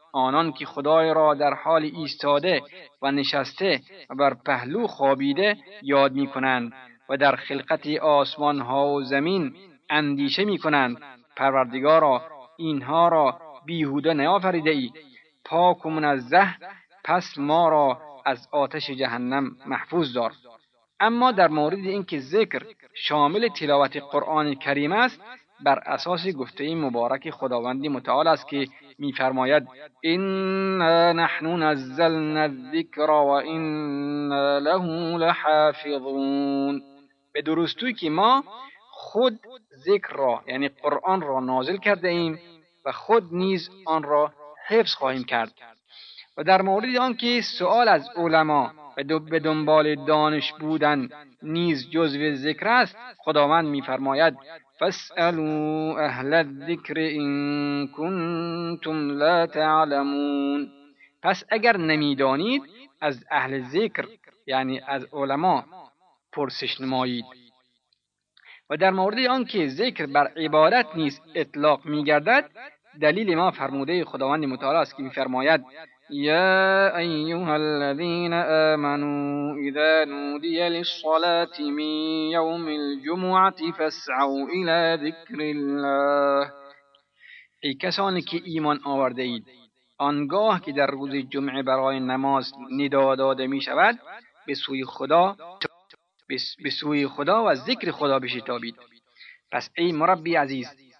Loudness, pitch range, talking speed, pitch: -23 LUFS, 140-170 Hz, 115 wpm, 150 Hz